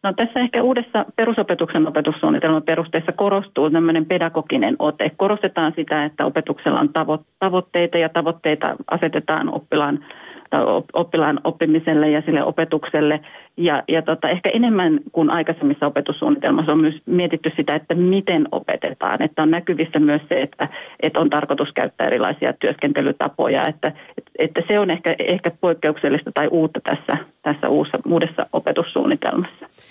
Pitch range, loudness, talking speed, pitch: 155-185 Hz, -19 LUFS, 135 wpm, 165 Hz